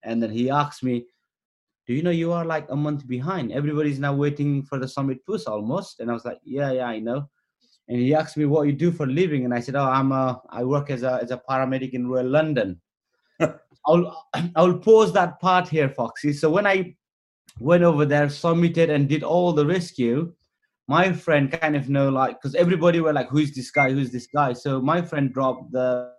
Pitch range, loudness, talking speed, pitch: 130-165 Hz, -22 LUFS, 225 wpm, 145 Hz